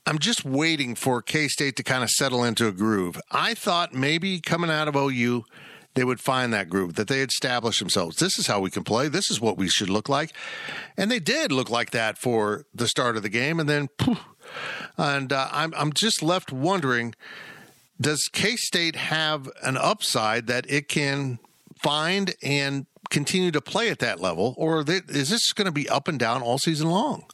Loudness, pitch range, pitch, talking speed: -24 LUFS, 120-165 Hz, 140 Hz, 205 wpm